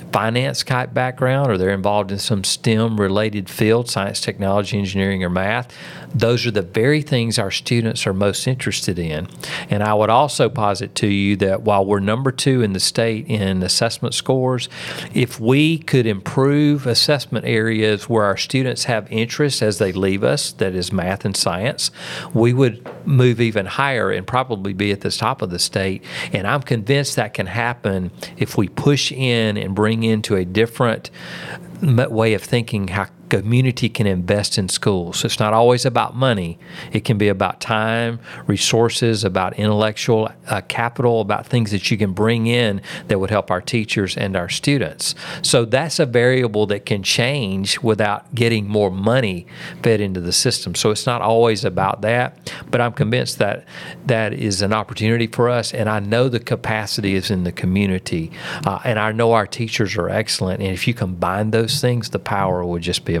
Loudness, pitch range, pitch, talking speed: -19 LUFS, 100-120 Hz, 110 Hz, 180 wpm